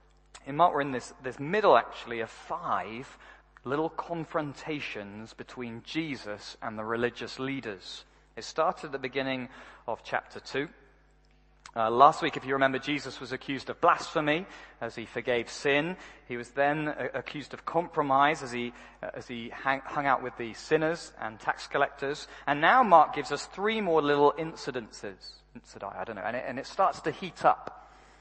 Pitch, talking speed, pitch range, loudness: 140 Hz, 180 wpm, 125-155 Hz, -29 LUFS